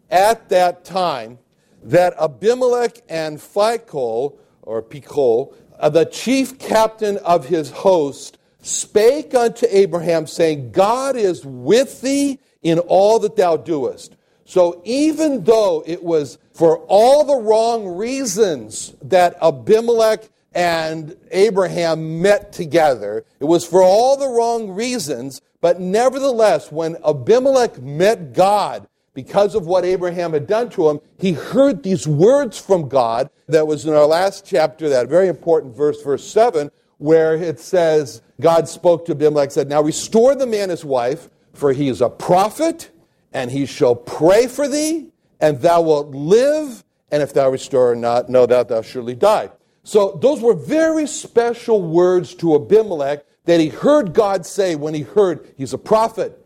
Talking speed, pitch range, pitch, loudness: 150 wpm, 155-235 Hz, 185 Hz, -17 LUFS